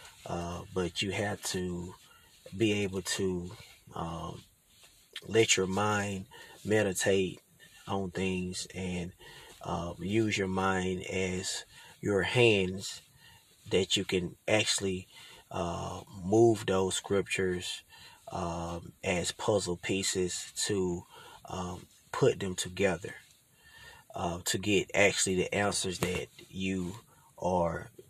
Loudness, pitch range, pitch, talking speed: -31 LUFS, 90-100 Hz, 95 Hz, 105 wpm